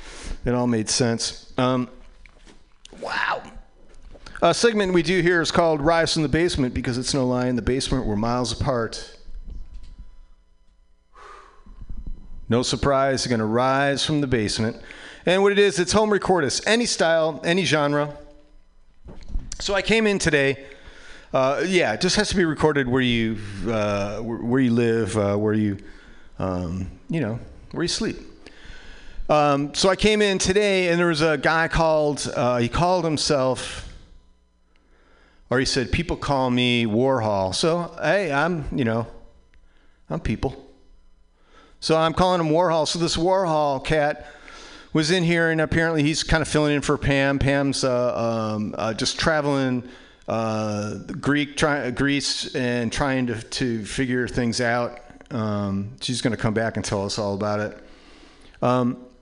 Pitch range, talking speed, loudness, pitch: 110-155 Hz, 160 wpm, -22 LUFS, 130 Hz